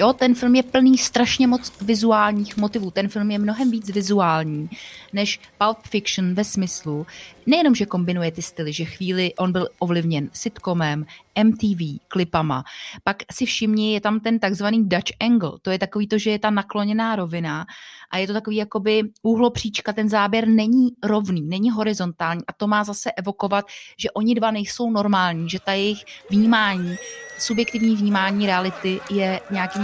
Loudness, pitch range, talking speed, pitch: -21 LUFS, 185-220 Hz, 165 wpm, 205 Hz